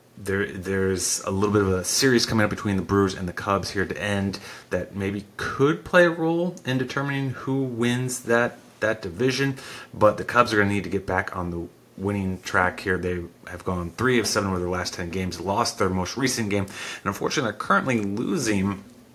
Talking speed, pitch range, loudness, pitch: 215 wpm, 95-120 Hz, -24 LUFS, 100 Hz